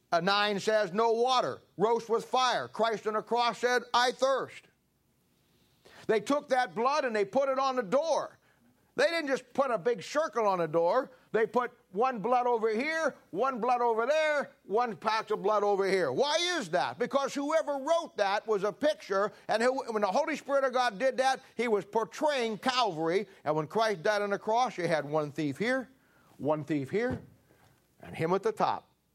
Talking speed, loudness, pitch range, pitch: 195 wpm, -30 LUFS, 210-265 Hz, 235 Hz